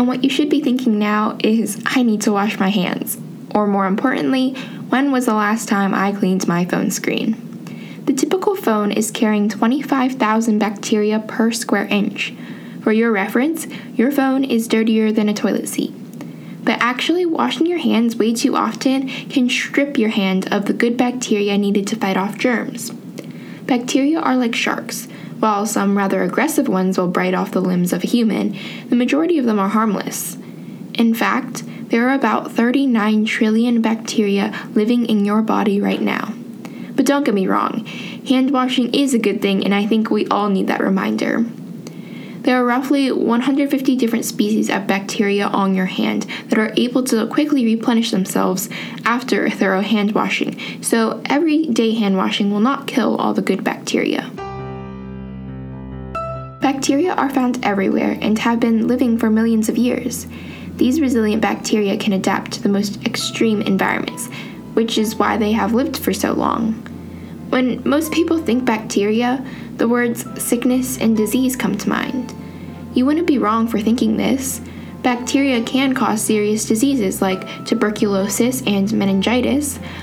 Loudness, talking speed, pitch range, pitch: -18 LUFS, 165 wpm, 210-255 Hz, 225 Hz